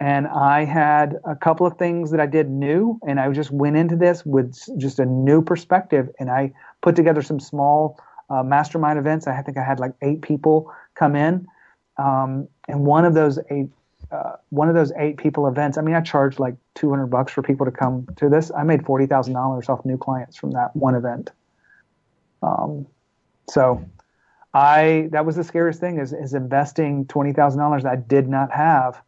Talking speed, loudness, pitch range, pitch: 190 wpm, -20 LUFS, 135-155 Hz, 145 Hz